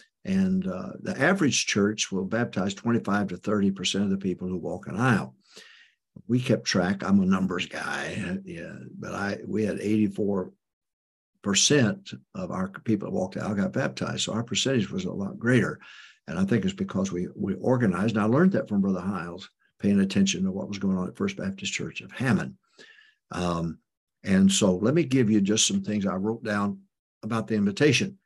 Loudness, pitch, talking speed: -26 LUFS, 110 Hz, 195 wpm